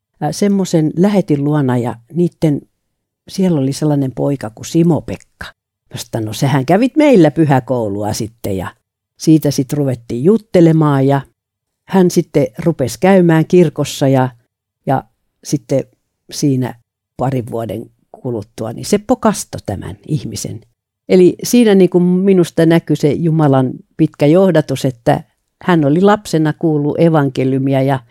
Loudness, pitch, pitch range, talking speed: -14 LUFS, 145 Hz, 125-170 Hz, 125 wpm